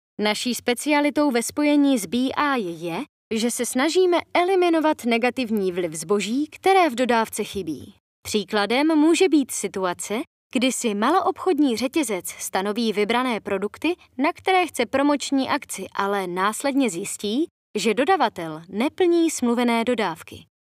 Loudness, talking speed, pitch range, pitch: -22 LUFS, 120 wpm, 210-295 Hz, 245 Hz